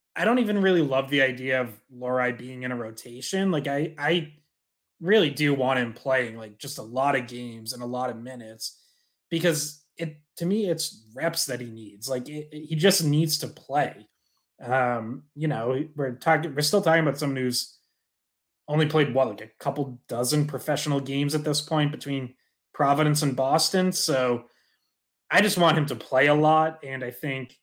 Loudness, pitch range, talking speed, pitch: -25 LUFS, 125-155 Hz, 190 wpm, 140 Hz